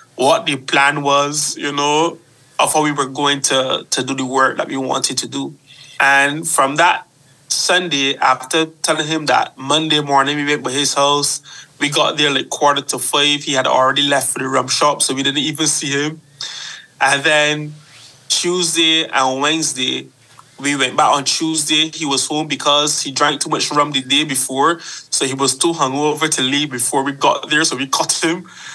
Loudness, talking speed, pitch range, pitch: -15 LUFS, 195 wpm, 135-155 Hz, 145 Hz